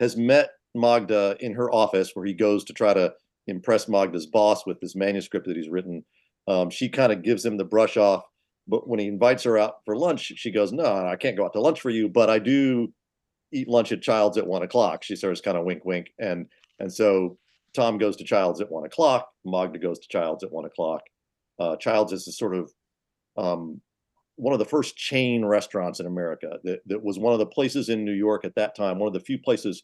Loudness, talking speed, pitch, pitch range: -24 LUFS, 230 wpm, 105 Hz, 95-120 Hz